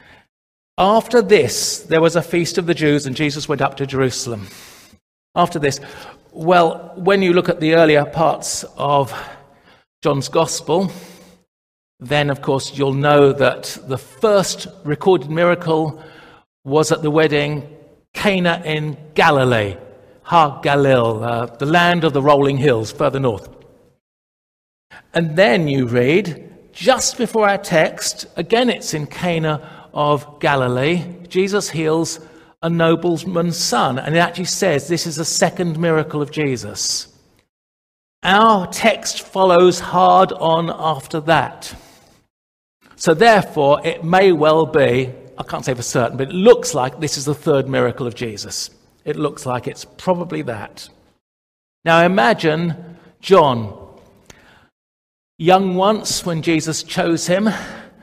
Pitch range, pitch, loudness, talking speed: 135-175 Hz, 160 Hz, -17 LUFS, 135 wpm